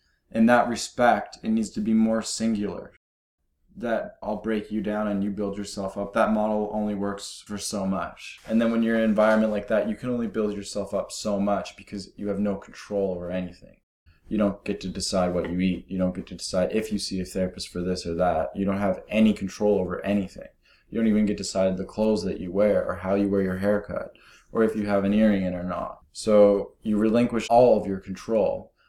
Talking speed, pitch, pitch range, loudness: 235 wpm, 100 Hz, 95-110 Hz, -25 LUFS